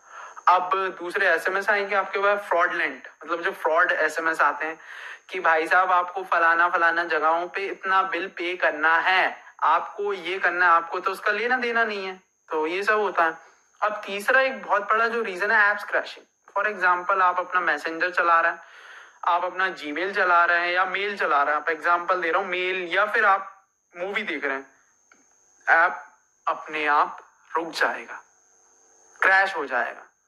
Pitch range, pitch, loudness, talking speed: 170-200 Hz, 185 Hz, -23 LUFS, 190 wpm